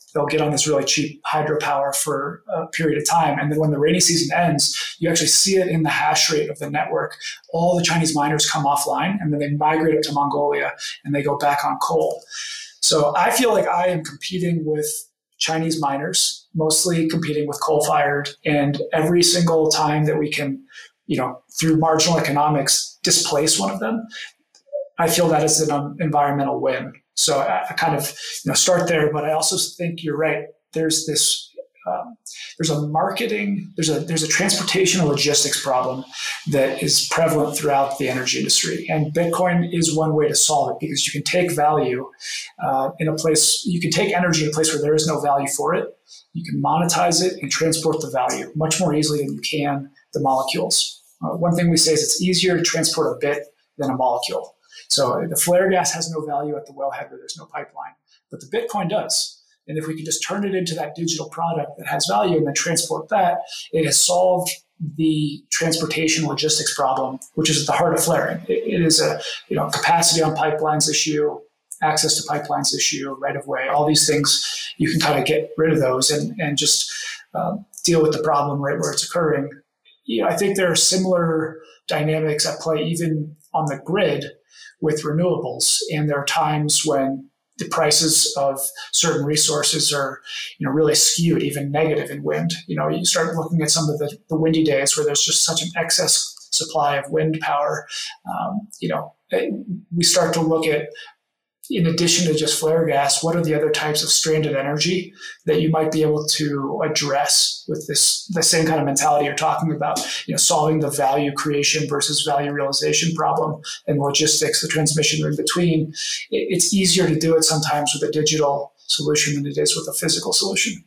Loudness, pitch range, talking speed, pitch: -19 LUFS, 150-170 Hz, 200 wpm, 155 Hz